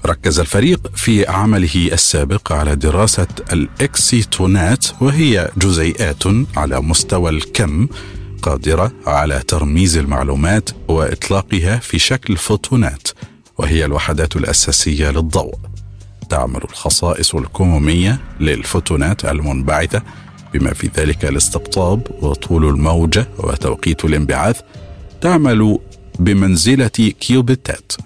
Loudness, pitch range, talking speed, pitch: -14 LUFS, 80-105 Hz, 90 wpm, 95 Hz